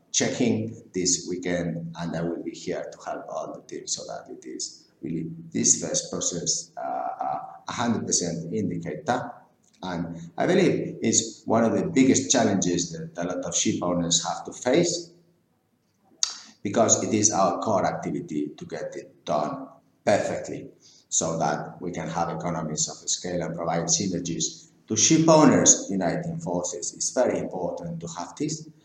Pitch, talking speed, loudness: 90 Hz, 155 wpm, -25 LUFS